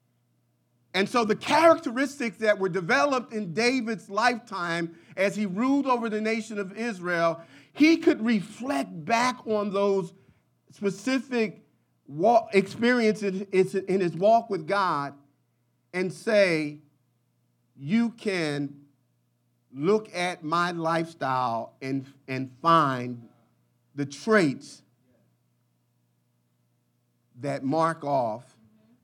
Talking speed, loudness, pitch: 95 wpm, -26 LUFS, 170 Hz